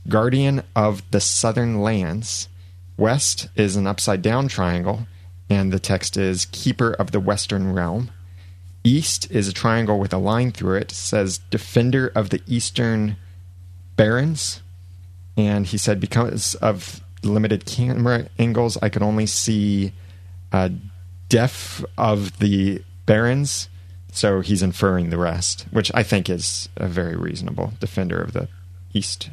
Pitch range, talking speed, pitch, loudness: 90-110 Hz, 135 wpm, 100 Hz, -21 LUFS